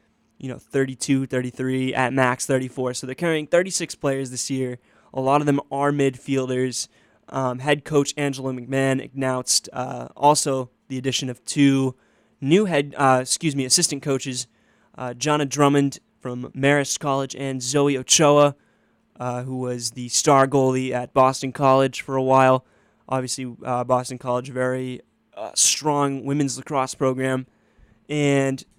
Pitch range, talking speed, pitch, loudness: 130-140 Hz, 150 wpm, 130 Hz, -21 LUFS